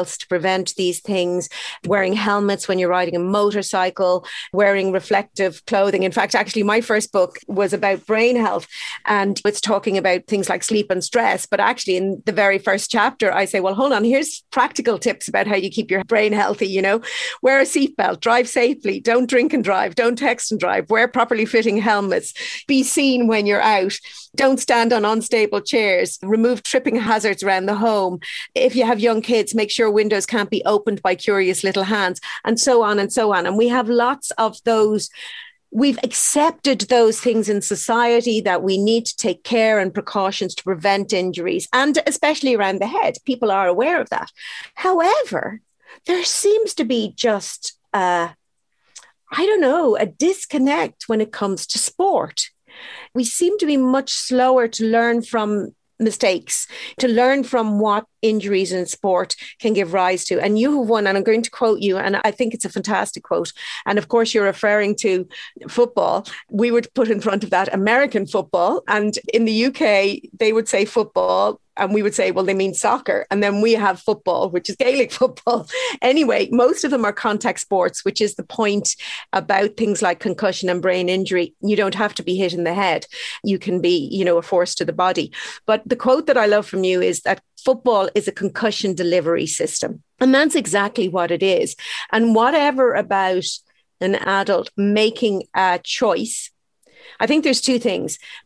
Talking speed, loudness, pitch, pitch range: 190 wpm, -19 LUFS, 215 Hz, 195-240 Hz